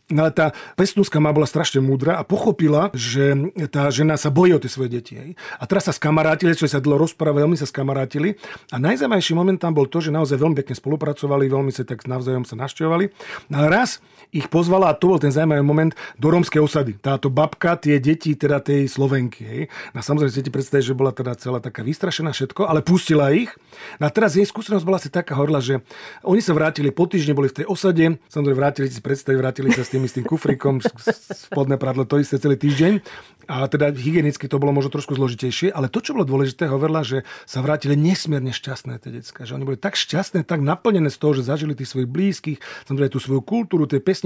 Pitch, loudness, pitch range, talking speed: 145 Hz, -20 LUFS, 135-165 Hz, 215 wpm